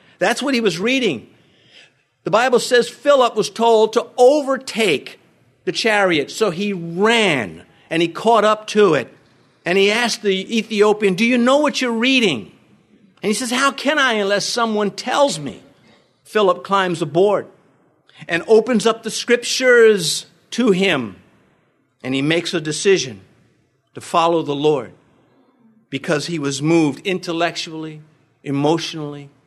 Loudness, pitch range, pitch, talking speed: -17 LUFS, 165-235 Hz, 200 Hz, 145 wpm